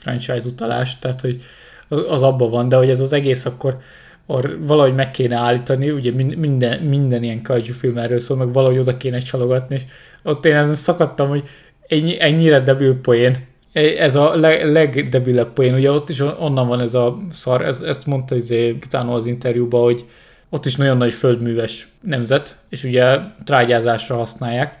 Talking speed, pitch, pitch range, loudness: 165 wpm, 130 Hz, 120-145 Hz, -17 LUFS